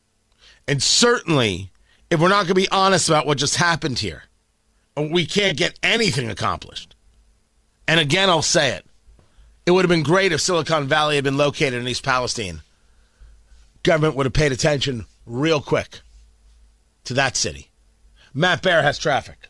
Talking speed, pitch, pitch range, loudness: 160 wpm, 145 Hz, 105-170 Hz, -19 LUFS